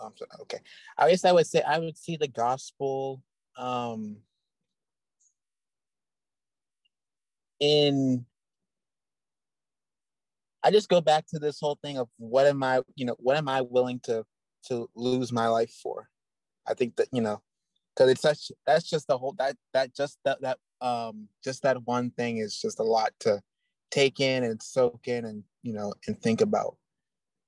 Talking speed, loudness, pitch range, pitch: 165 wpm, -27 LUFS, 120-150 Hz, 130 Hz